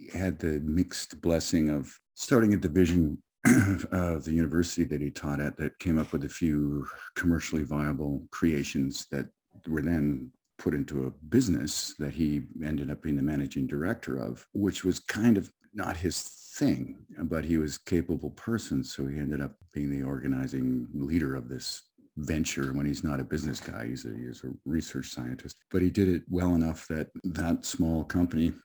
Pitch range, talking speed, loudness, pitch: 70-85 Hz, 180 wpm, -30 LUFS, 75 Hz